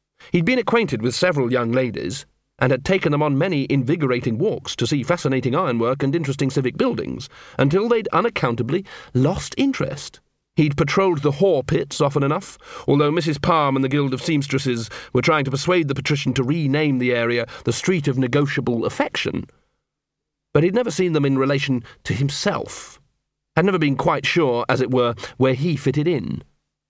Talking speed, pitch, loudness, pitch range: 175 wpm, 140 Hz, -20 LUFS, 130-165 Hz